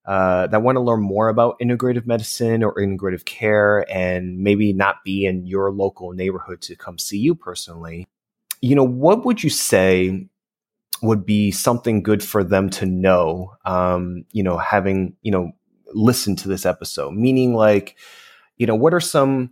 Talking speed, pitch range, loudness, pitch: 170 wpm, 95-120 Hz, -19 LUFS, 100 Hz